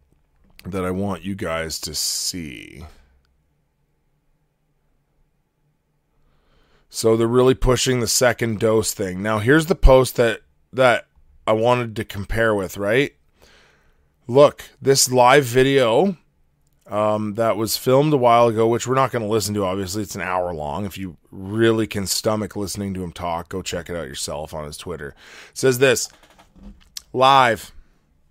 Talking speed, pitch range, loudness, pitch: 150 wpm, 90-125 Hz, -19 LUFS, 110 Hz